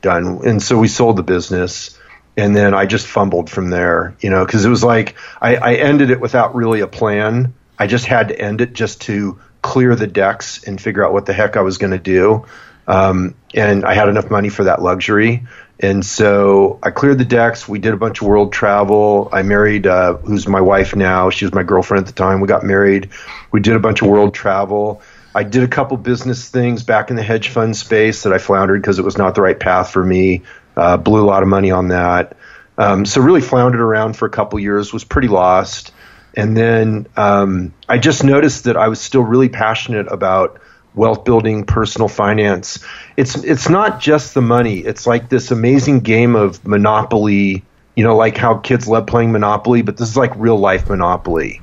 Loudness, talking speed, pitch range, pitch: -13 LUFS, 215 wpm, 100-115 Hz, 105 Hz